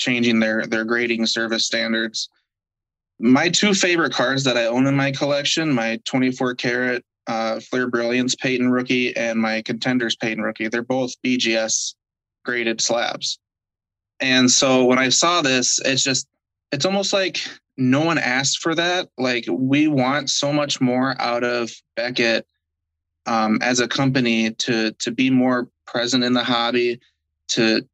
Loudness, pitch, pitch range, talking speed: -19 LUFS, 125 Hz, 115-130 Hz, 155 wpm